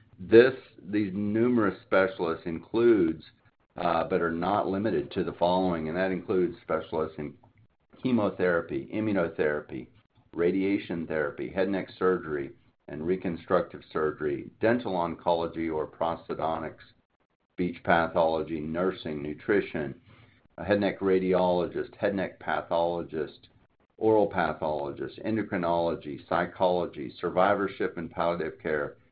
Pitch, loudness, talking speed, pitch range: 90 Hz, -28 LUFS, 105 wpm, 85-105 Hz